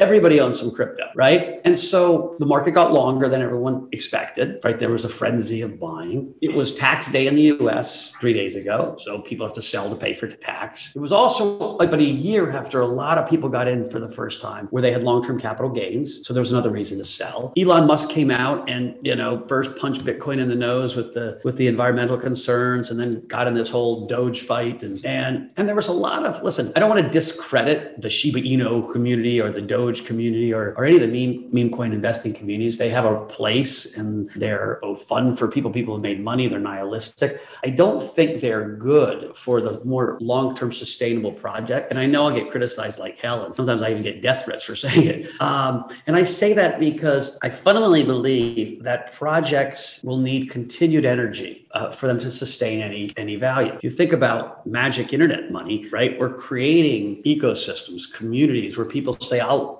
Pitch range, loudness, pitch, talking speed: 115-150 Hz, -21 LUFS, 125 Hz, 215 wpm